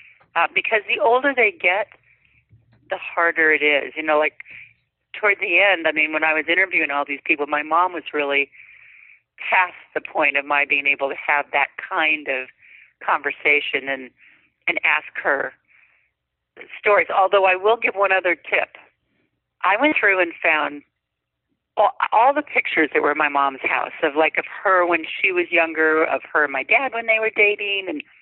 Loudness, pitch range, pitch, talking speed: -19 LUFS, 145-195 Hz, 160 Hz, 185 wpm